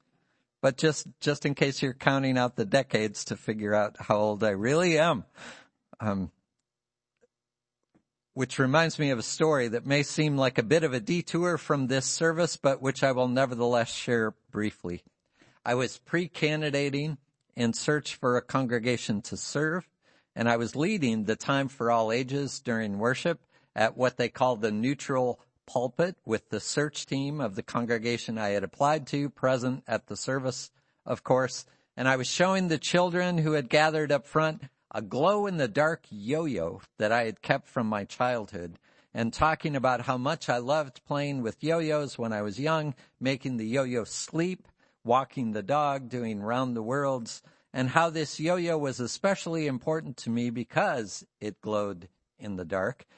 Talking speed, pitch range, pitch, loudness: 175 wpm, 120-155 Hz, 135 Hz, -28 LUFS